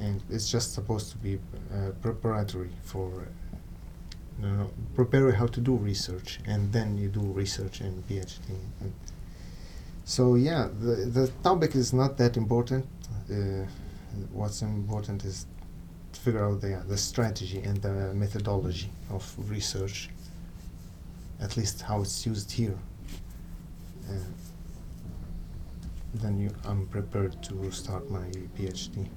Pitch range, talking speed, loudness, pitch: 90-105 Hz, 130 wpm, -31 LUFS, 100 Hz